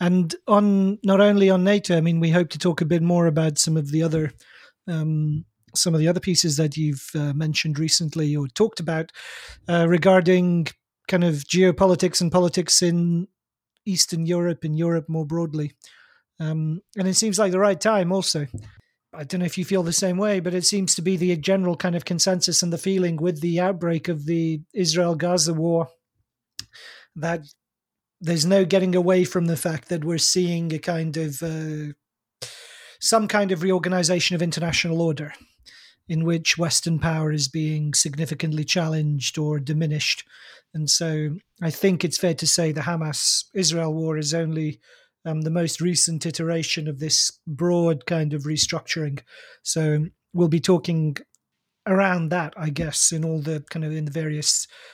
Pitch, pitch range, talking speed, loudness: 170 Hz, 155-180 Hz, 175 wpm, -22 LUFS